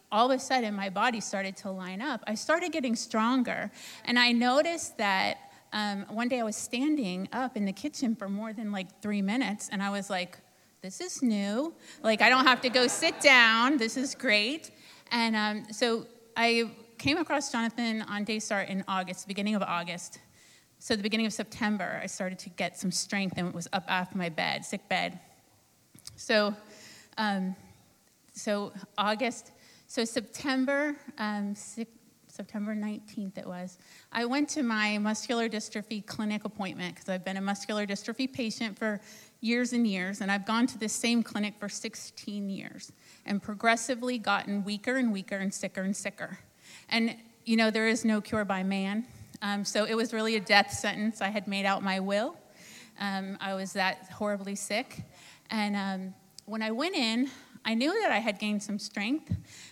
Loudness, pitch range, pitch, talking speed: -30 LUFS, 200-235 Hz, 215 Hz, 180 wpm